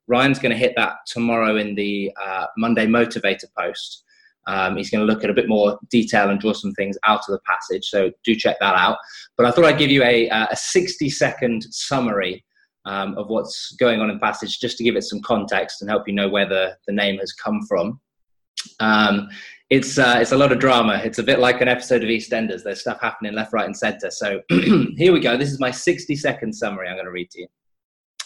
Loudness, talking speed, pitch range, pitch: -19 LUFS, 225 wpm, 100-125 Hz, 115 Hz